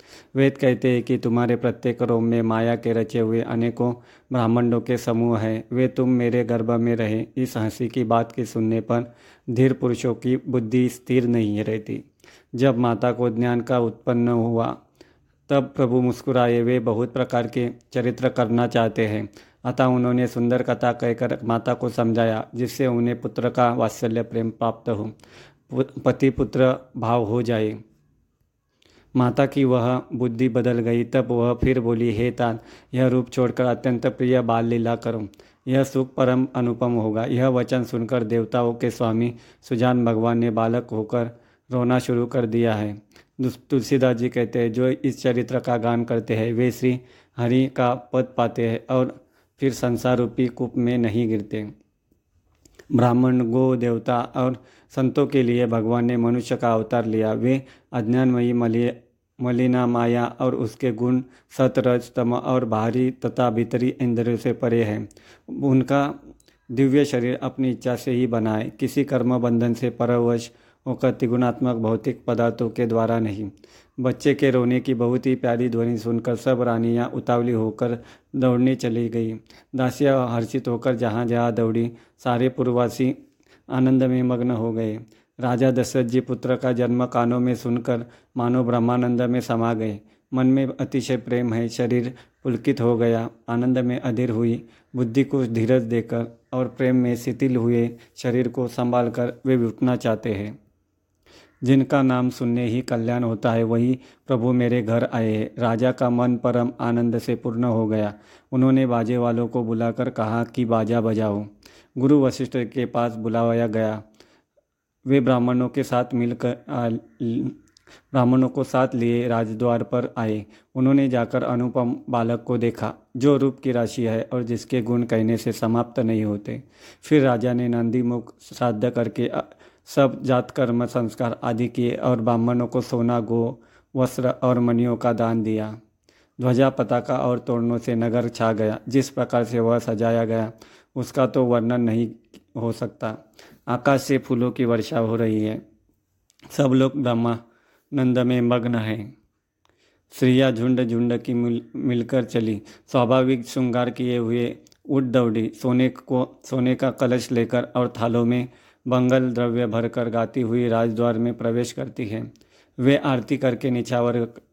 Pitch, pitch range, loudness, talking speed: 120 Hz, 115-125 Hz, -22 LUFS, 155 wpm